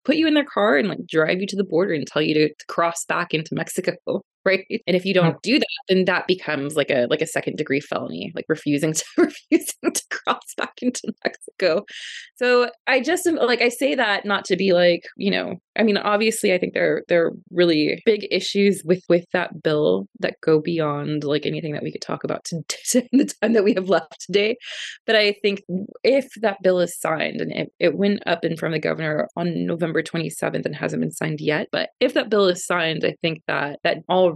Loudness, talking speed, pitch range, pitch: -21 LUFS, 230 wpm, 160-220 Hz, 185 Hz